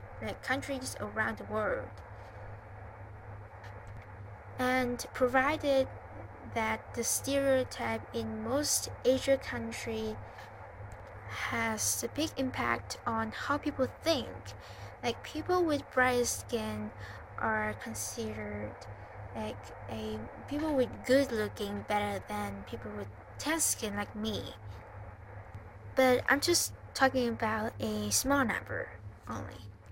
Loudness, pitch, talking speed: -33 LUFS, 110 Hz, 105 wpm